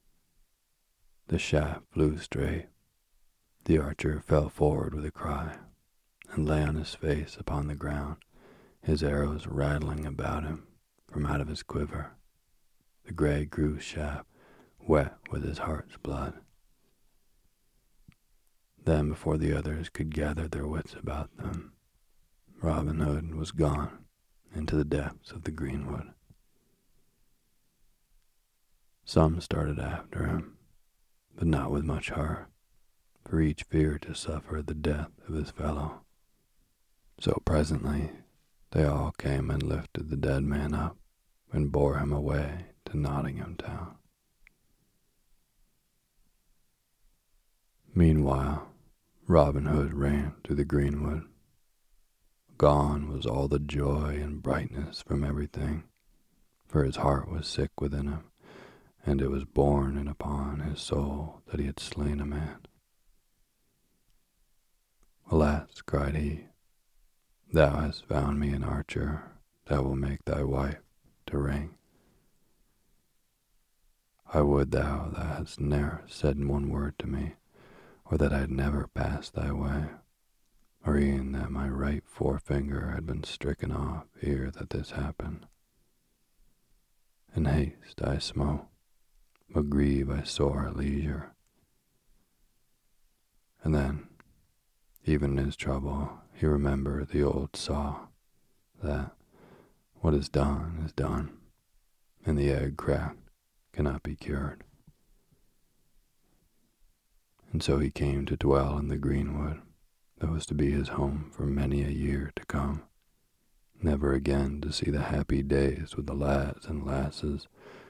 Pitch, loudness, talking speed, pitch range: 75 Hz, -31 LUFS, 125 wpm, 70-75 Hz